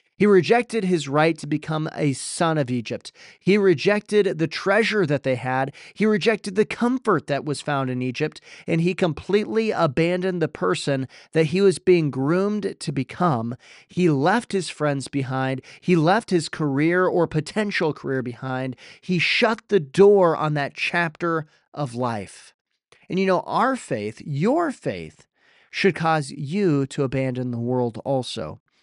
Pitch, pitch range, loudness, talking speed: 160 Hz, 140-195 Hz, -22 LUFS, 160 wpm